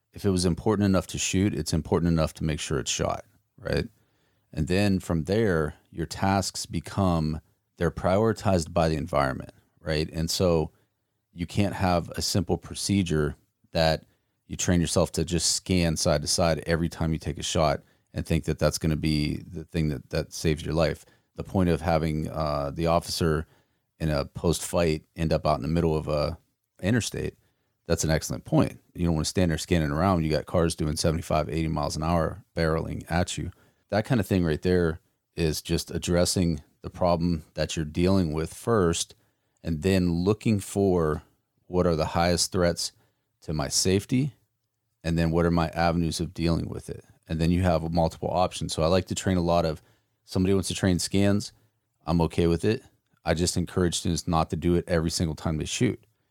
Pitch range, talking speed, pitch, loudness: 80-95 Hz, 195 wpm, 85 Hz, -26 LUFS